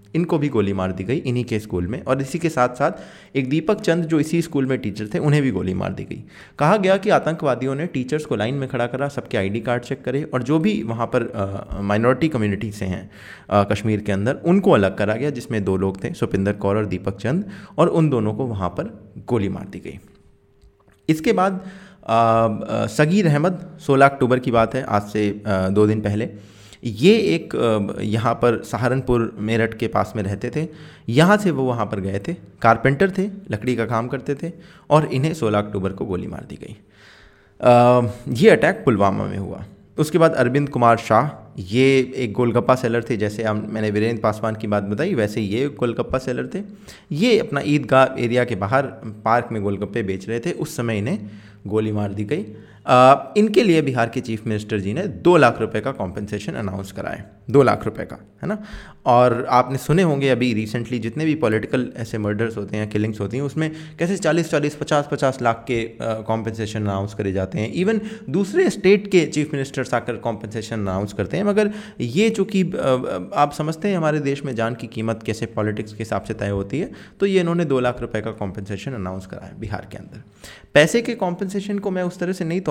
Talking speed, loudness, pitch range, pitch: 205 wpm, -20 LUFS, 105-150 Hz, 120 Hz